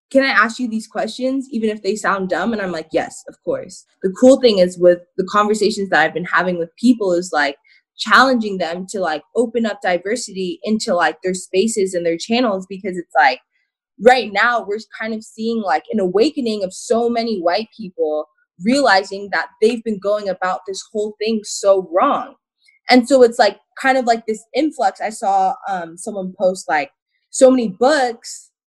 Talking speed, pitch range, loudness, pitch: 190 wpm, 185-245 Hz, -17 LUFS, 215 Hz